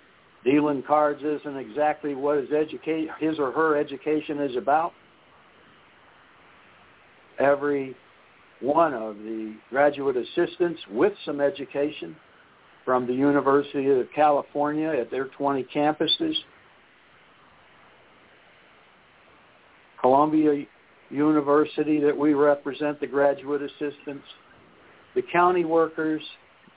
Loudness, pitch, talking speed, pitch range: -24 LUFS, 145 Hz, 90 wpm, 140-155 Hz